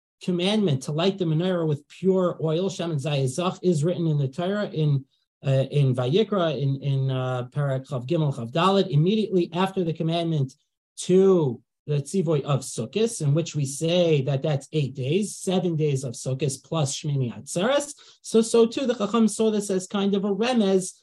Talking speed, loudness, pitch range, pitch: 185 wpm, -24 LUFS, 140-190 Hz, 165 Hz